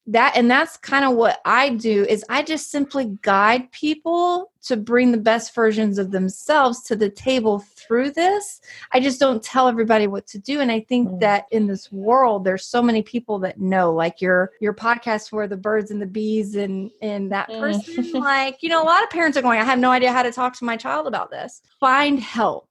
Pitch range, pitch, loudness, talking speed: 210-270 Hz, 235 Hz, -20 LUFS, 220 wpm